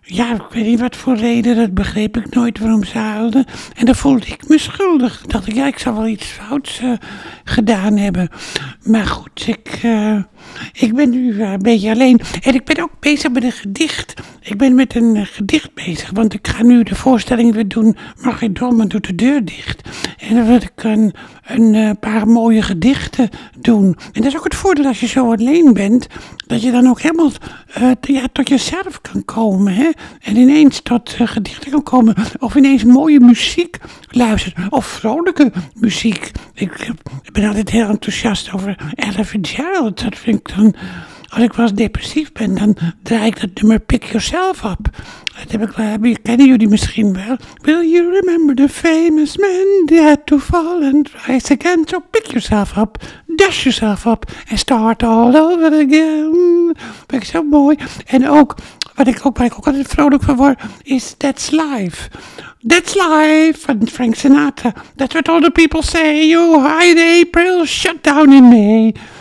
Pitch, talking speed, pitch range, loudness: 245 Hz, 185 wpm, 220-295 Hz, -13 LUFS